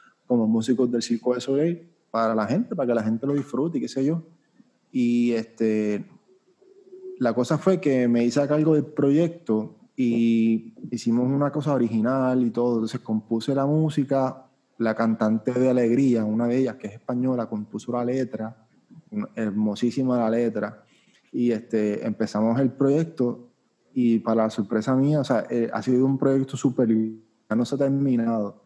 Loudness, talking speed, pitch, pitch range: -24 LUFS, 170 wpm, 125 Hz, 115-140 Hz